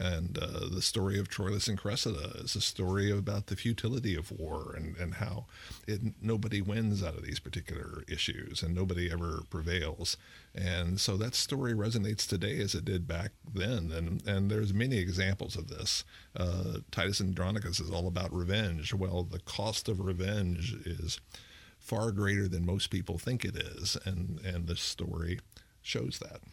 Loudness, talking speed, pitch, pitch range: -34 LUFS, 170 wpm, 95 Hz, 90-105 Hz